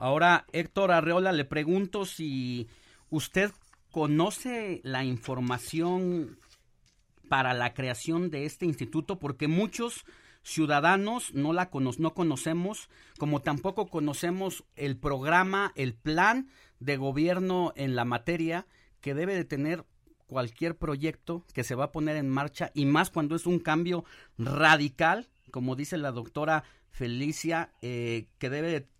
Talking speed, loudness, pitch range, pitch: 135 wpm, -29 LUFS, 135-175 Hz, 155 Hz